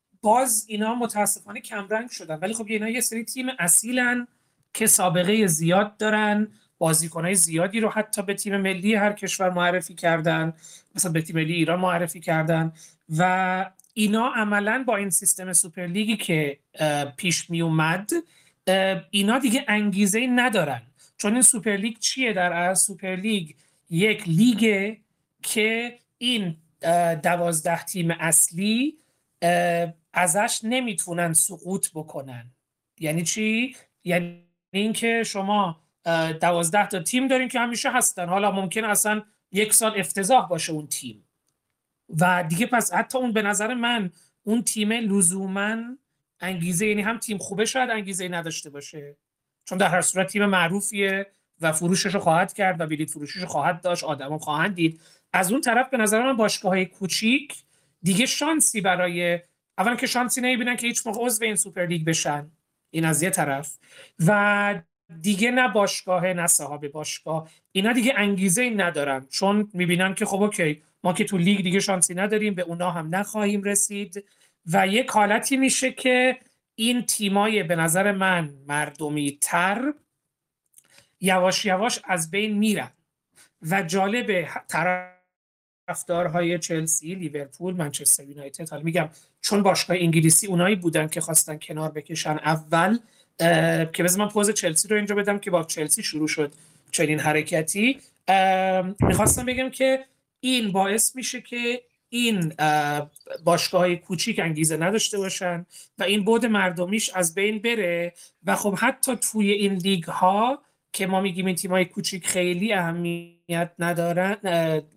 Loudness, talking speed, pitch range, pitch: -23 LUFS, 140 wpm, 170-215 Hz, 190 Hz